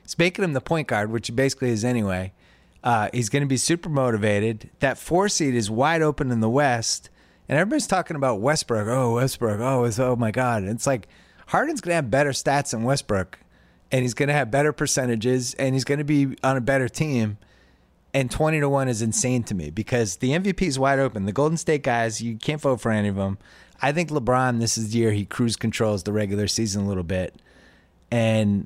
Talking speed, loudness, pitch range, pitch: 220 wpm, -23 LUFS, 110-140 Hz, 125 Hz